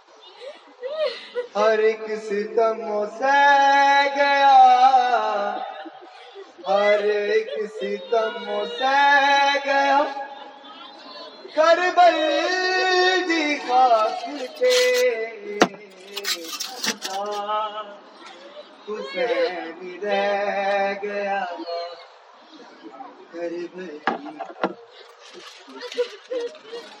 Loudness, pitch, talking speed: -20 LUFS, 275 Hz, 40 wpm